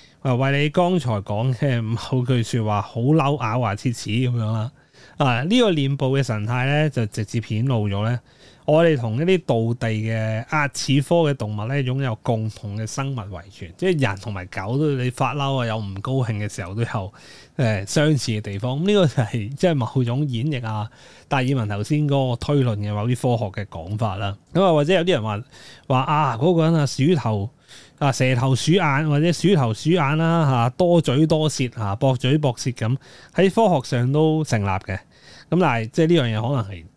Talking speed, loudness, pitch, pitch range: 295 characters per minute, -21 LUFS, 130 Hz, 110-150 Hz